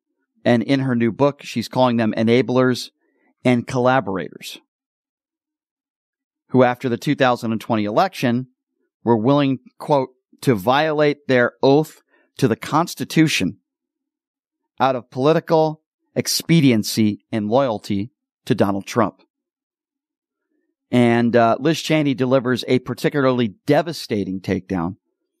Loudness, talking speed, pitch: -19 LUFS, 105 wpm, 135 Hz